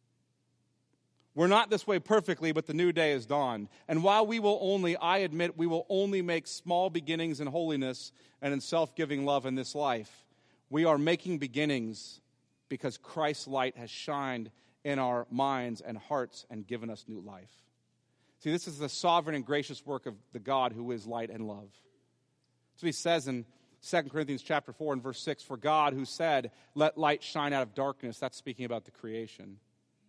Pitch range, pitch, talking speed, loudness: 125-165 Hz, 140 Hz, 185 wpm, -32 LUFS